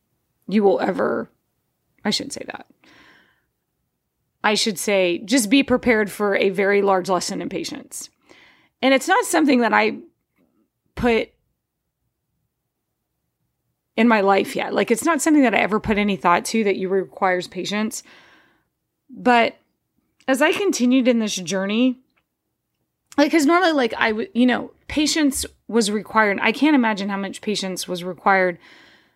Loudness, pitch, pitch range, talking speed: -19 LUFS, 220 Hz, 195-260 Hz, 150 wpm